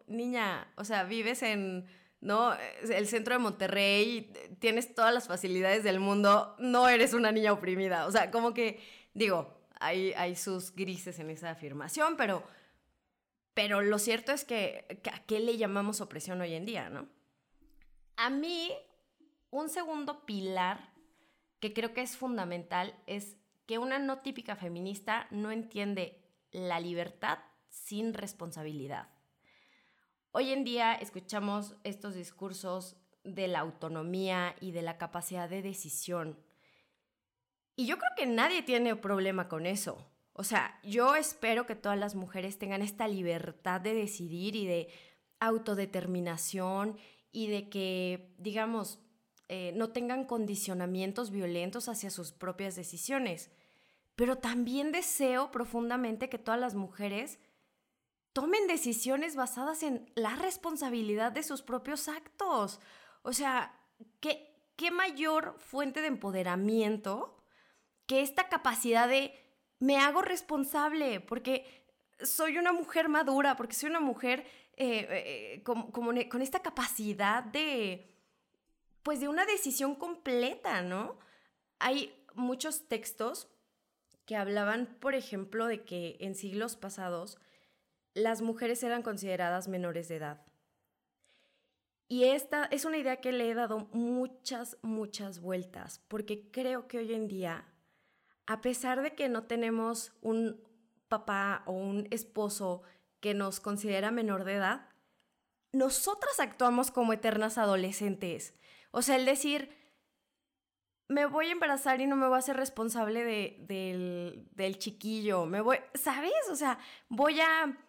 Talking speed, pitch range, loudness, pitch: 135 wpm, 195-260 Hz, -33 LUFS, 225 Hz